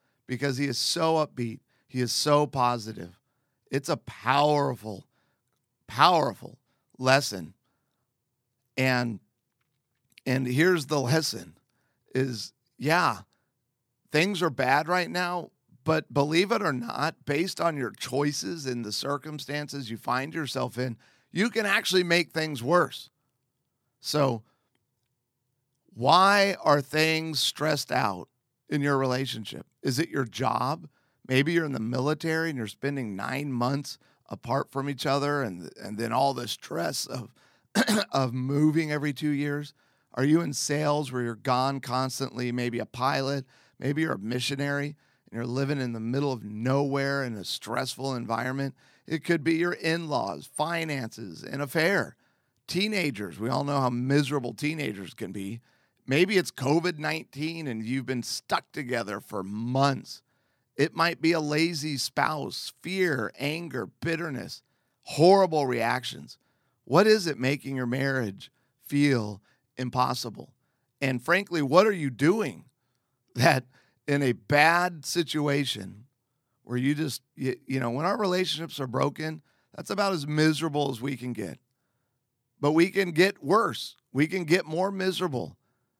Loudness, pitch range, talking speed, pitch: -27 LUFS, 125-155 Hz, 140 wpm, 140 Hz